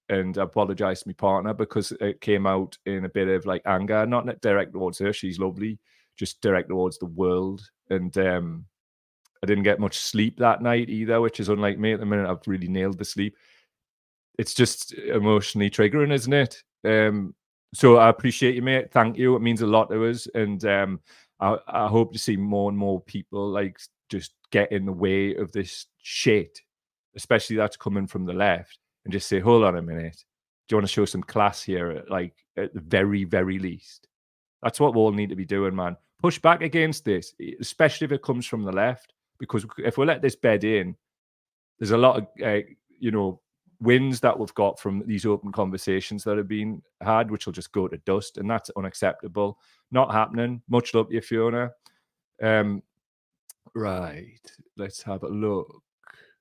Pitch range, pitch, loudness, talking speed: 95-115 Hz, 105 Hz, -24 LUFS, 195 wpm